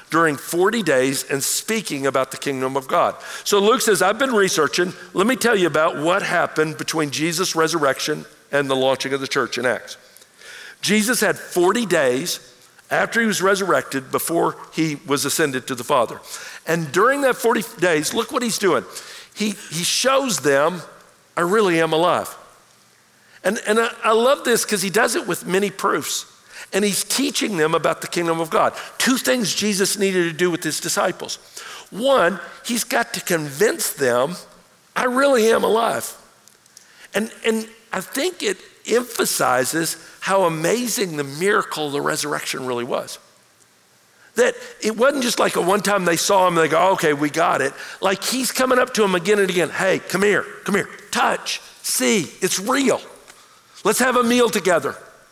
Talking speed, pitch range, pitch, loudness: 175 wpm, 160-235 Hz, 195 Hz, -20 LUFS